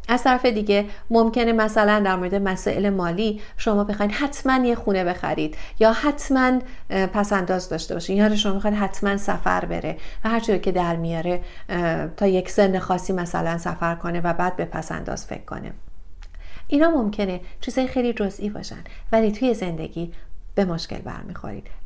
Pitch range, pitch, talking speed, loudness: 180-220 Hz, 200 Hz, 160 wpm, -22 LUFS